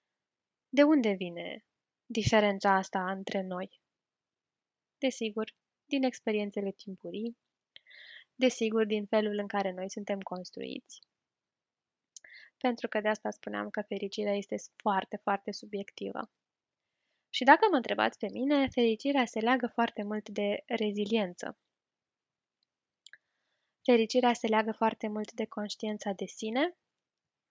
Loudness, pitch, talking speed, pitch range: -31 LUFS, 215 Hz, 115 wpm, 200-235 Hz